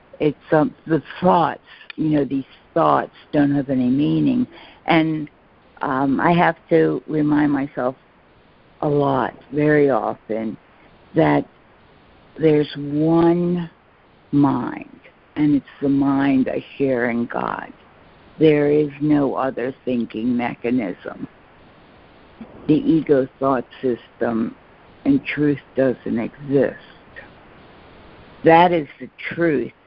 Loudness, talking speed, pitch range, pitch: -20 LUFS, 105 wpm, 130-160 Hz, 145 Hz